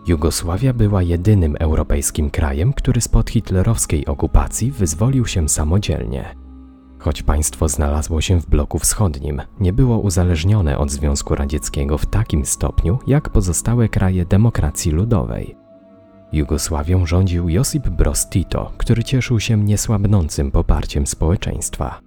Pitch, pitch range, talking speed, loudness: 90 Hz, 75-105 Hz, 115 wpm, -18 LUFS